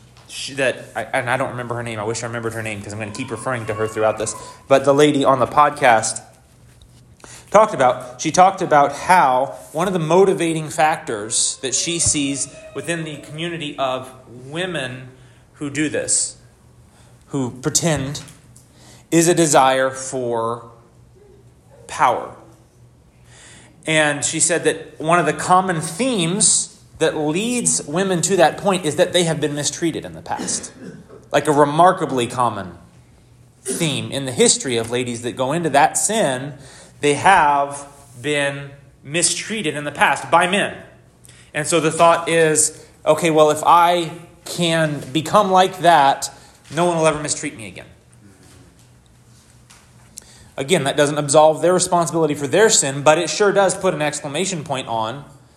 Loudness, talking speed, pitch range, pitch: -18 LUFS, 160 wpm, 130-165 Hz, 150 Hz